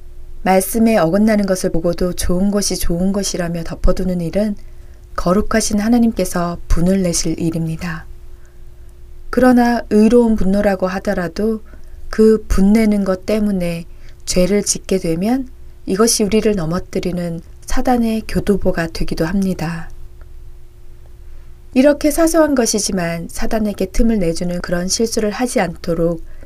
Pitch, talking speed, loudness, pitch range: 190 Hz, 285 characters per minute, -16 LUFS, 170-220 Hz